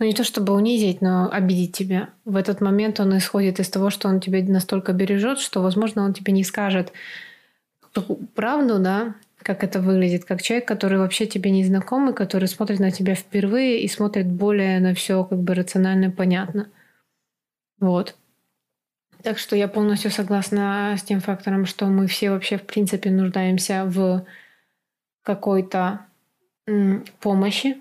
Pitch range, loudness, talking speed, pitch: 190-210 Hz, -21 LUFS, 160 wpm, 195 Hz